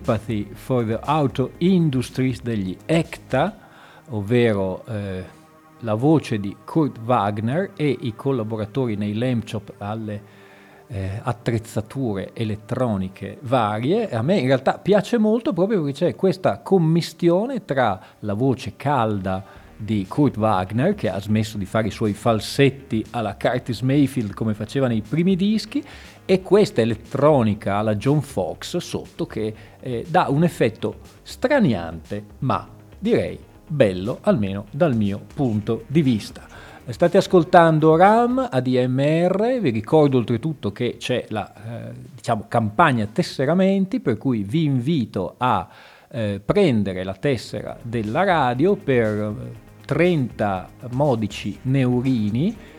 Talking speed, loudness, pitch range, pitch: 125 wpm, -21 LUFS, 105-150 Hz, 120 Hz